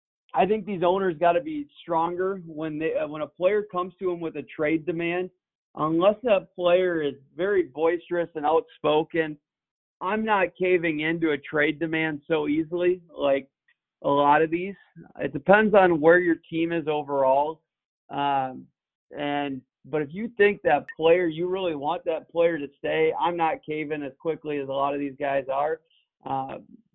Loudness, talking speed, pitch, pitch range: -25 LUFS, 175 wpm, 160 Hz, 150-180 Hz